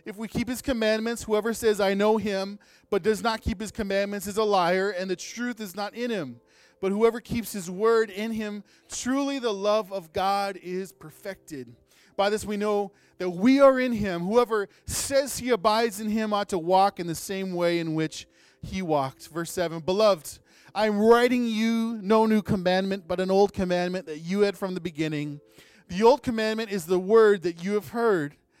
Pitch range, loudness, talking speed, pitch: 185-220 Hz, -25 LUFS, 200 wpm, 205 Hz